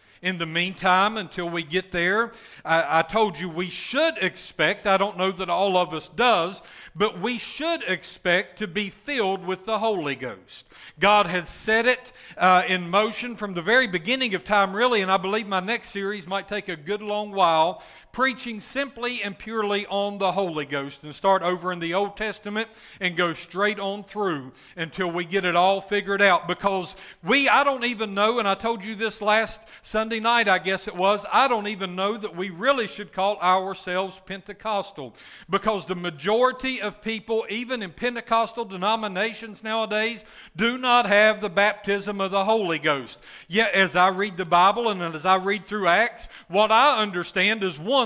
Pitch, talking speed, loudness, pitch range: 200 Hz, 190 wpm, -23 LUFS, 185-220 Hz